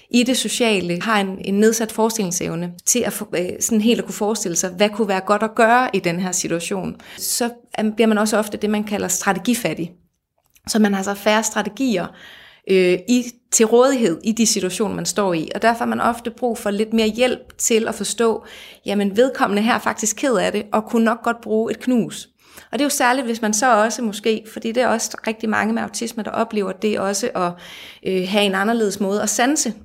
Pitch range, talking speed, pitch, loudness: 200-235 Hz, 220 wpm, 220 Hz, -19 LUFS